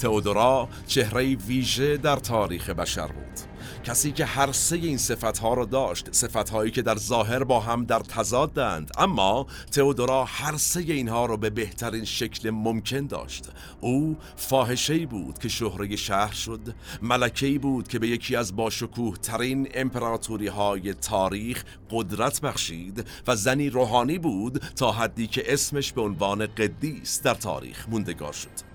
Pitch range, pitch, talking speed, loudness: 105-130 Hz, 115 Hz, 150 wpm, -26 LUFS